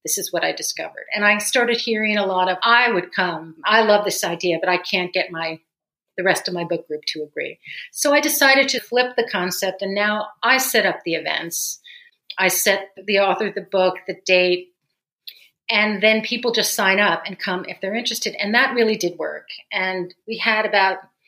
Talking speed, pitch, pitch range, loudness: 210 wpm, 195 Hz, 180-225 Hz, -19 LUFS